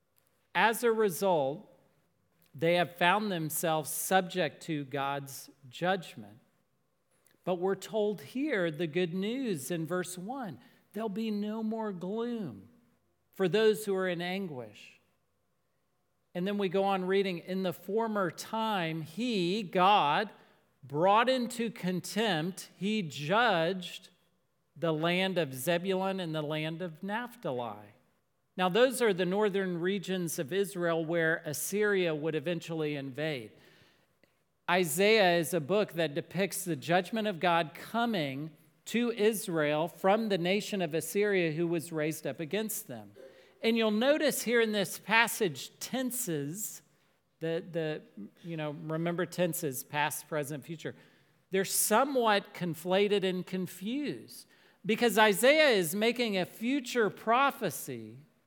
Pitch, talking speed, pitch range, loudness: 180 Hz, 125 wpm, 160-210 Hz, -31 LUFS